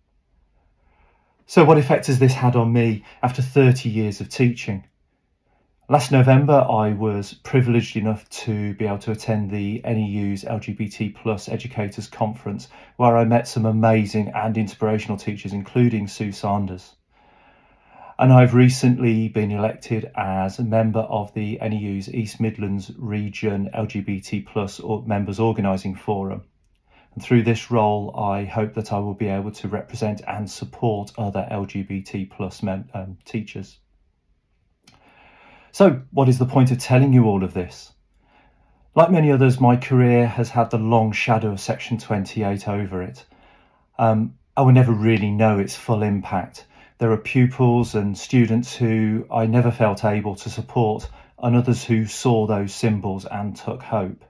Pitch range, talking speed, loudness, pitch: 100-120 Hz, 150 wpm, -20 LUFS, 110 Hz